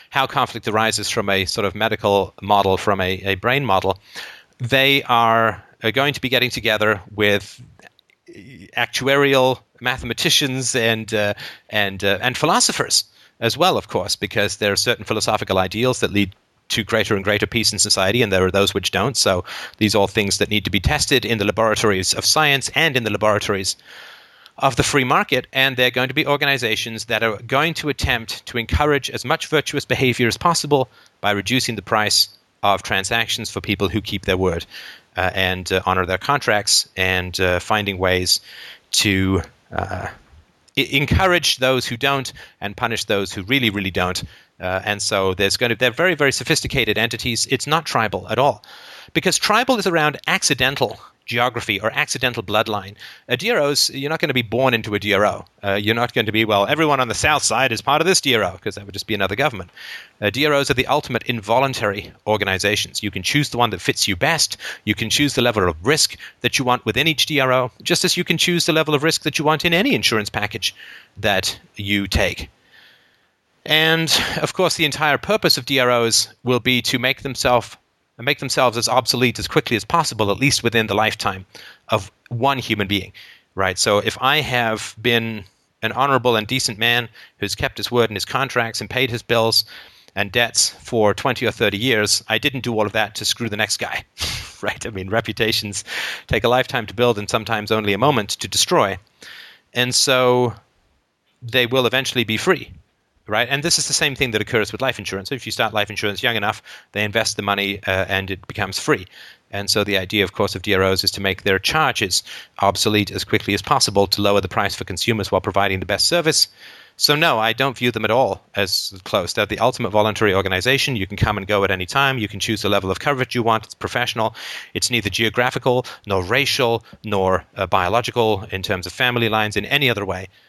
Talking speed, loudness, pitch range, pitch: 205 wpm, -18 LUFS, 100-130 Hz, 115 Hz